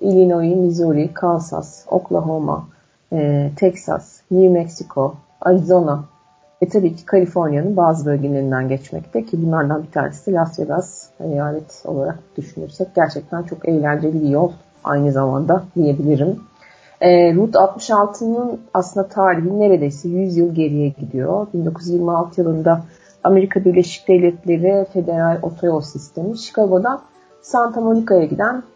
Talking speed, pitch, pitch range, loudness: 115 wpm, 170 Hz, 150-185 Hz, -17 LUFS